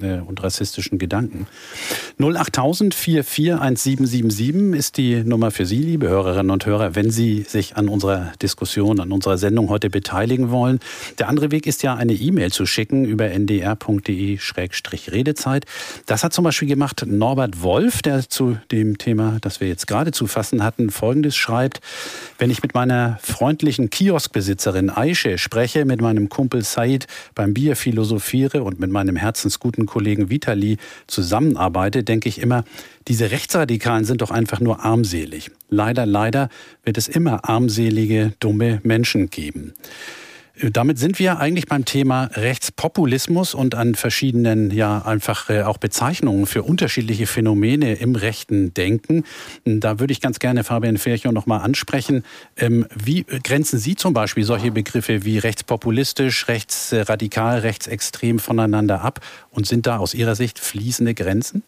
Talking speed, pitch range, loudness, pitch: 145 wpm, 105-135 Hz, -19 LUFS, 115 Hz